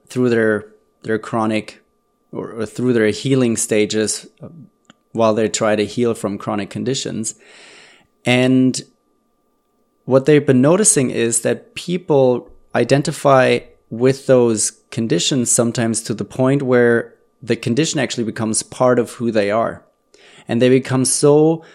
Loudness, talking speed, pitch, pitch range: -17 LUFS, 130 wpm, 120 Hz, 110-130 Hz